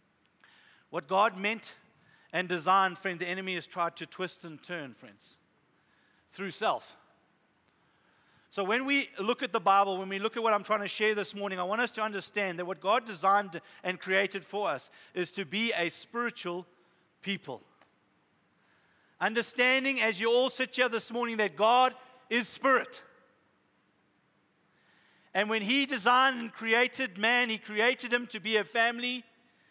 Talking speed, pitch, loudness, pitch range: 160 wpm, 210 Hz, -29 LUFS, 190-240 Hz